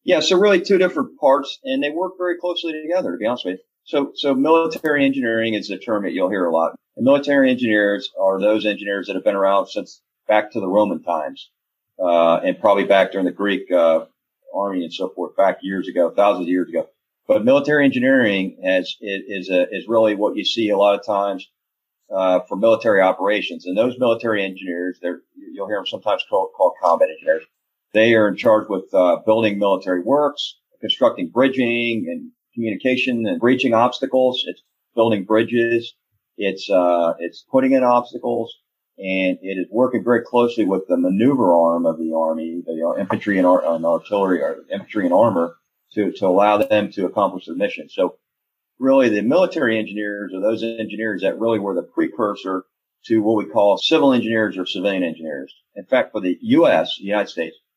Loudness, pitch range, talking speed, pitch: -19 LUFS, 95-140 Hz, 190 wpm, 110 Hz